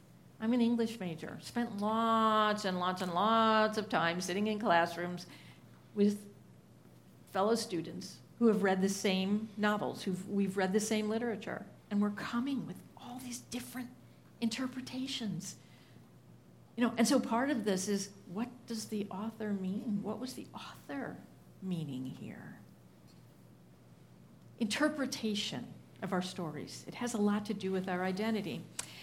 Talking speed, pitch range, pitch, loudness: 145 wpm, 185-230 Hz, 210 Hz, -34 LUFS